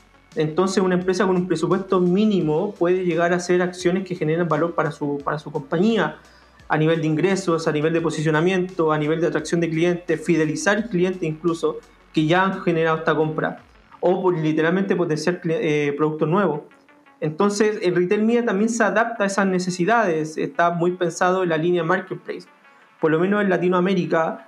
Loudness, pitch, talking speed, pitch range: -21 LUFS, 175 Hz, 175 wpm, 160-185 Hz